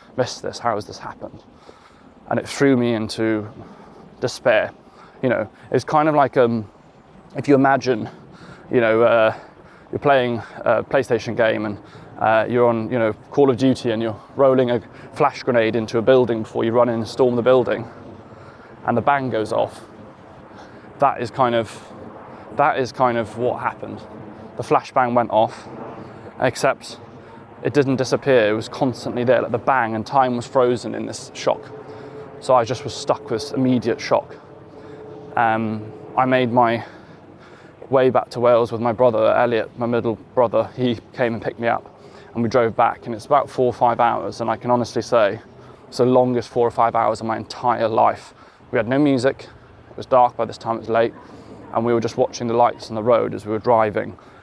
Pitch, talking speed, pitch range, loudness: 120 Hz, 195 wpm, 110-130 Hz, -20 LUFS